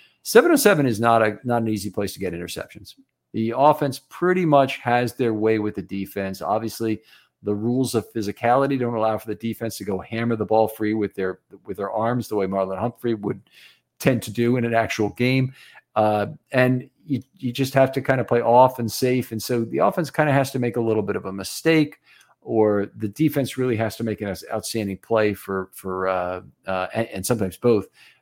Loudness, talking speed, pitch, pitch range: -22 LUFS, 215 wpm, 115 Hz, 105-125 Hz